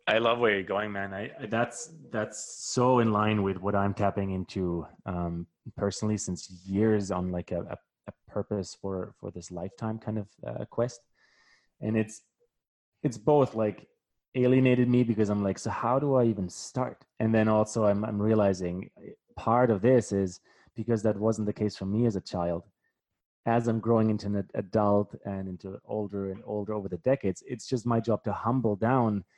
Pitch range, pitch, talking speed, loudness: 95-115 Hz, 105 Hz, 185 wpm, -29 LUFS